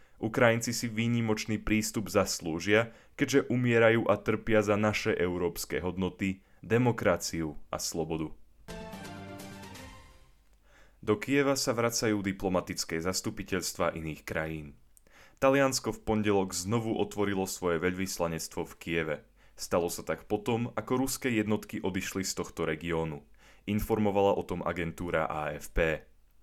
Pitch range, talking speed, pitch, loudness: 85-110 Hz, 110 wpm, 100 Hz, -30 LUFS